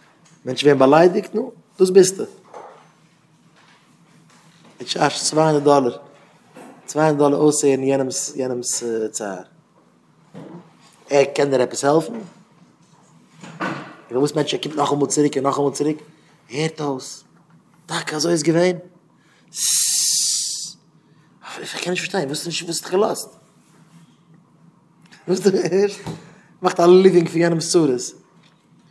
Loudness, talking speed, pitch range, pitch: -18 LUFS, 135 wpm, 145-175 Hz, 155 Hz